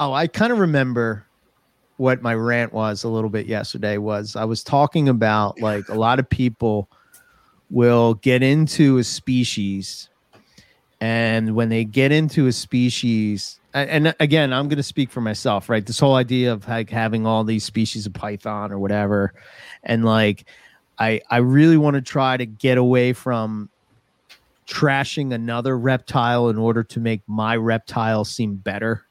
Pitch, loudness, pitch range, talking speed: 115 Hz, -20 LUFS, 110-130 Hz, 165 wpm